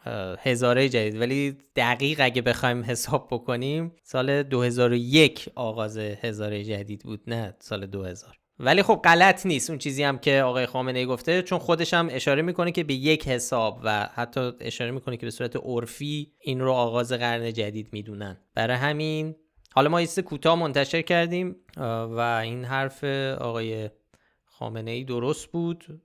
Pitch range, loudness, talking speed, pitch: 115-150 Hz, -25 LUFS, 155 wpm, 125 Hz